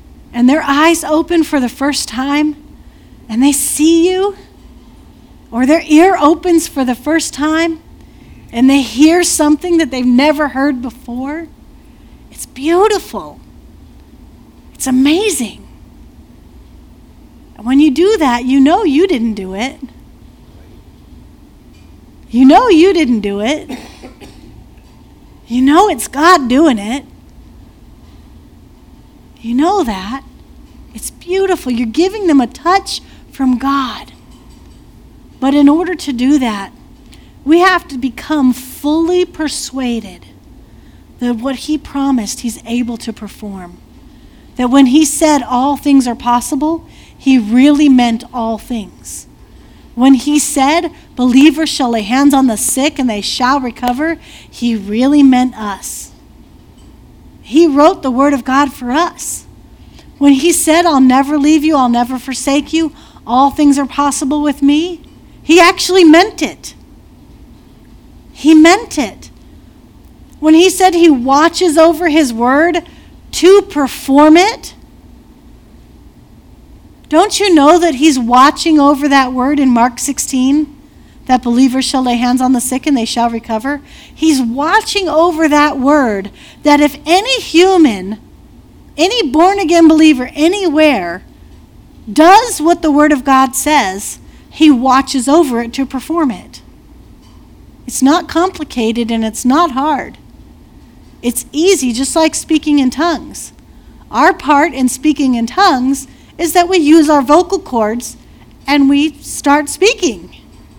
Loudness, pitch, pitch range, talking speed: -11 LUFS, 285 Hz, 255-320 Hz, 130 wpm